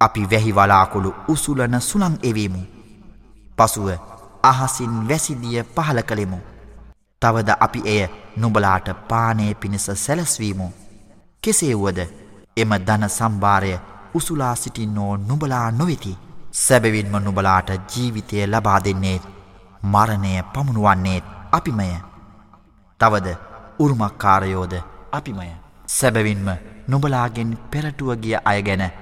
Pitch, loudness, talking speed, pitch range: 105 Hz, -20 LUFS, 85 wpm, 95-120 Hz